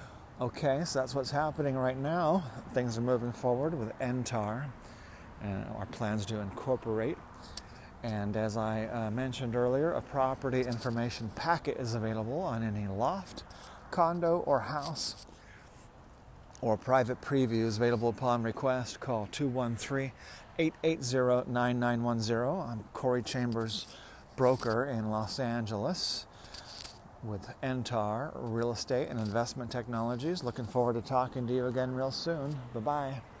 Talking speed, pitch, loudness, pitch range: 130 wpm, 120 Hz, -33 LUFS, 115-130 Hz